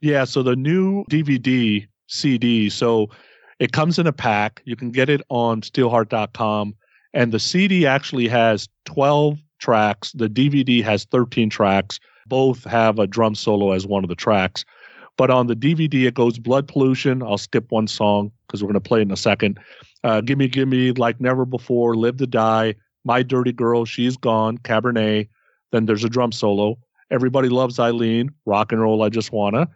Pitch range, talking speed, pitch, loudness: 110-130 Hz, 180 wpm, 120 Hz, -19 LUFS